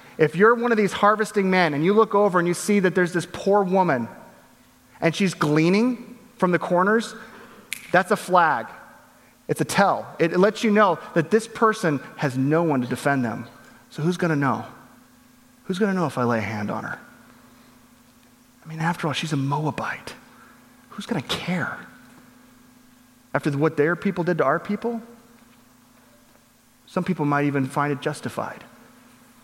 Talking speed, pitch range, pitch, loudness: 175 wpm, 145-205 Hz, 175 Hz, -22 LUFS